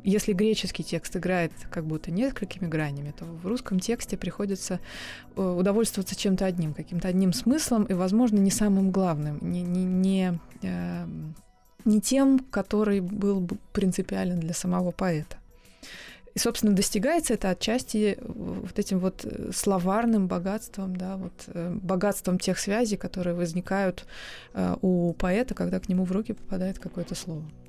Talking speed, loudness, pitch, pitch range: 135 wpm, -27 LUFS, 190 Hz, 180-205 Hz